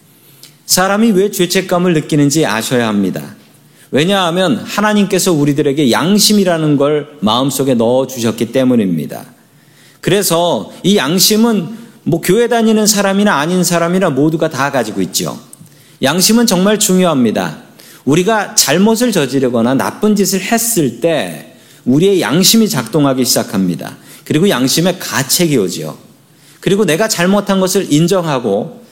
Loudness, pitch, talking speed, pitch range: -12 LUFS, 175 Hz, 315 characters per minute, 140-200 Hz